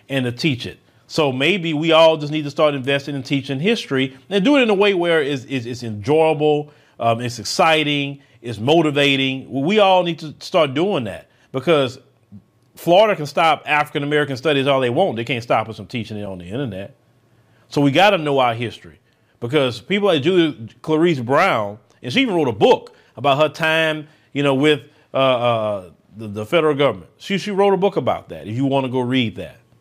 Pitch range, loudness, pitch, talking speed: 120-160 Hz, -18 LUFS, 140 Hz, 210 wpm